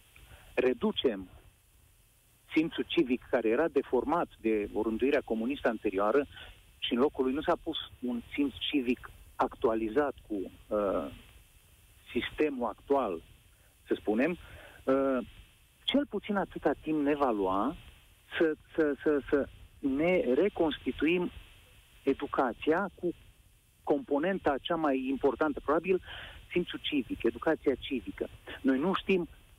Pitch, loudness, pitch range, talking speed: 135 Hz, -31 LUFS, 105-155 Hz, 110 wpm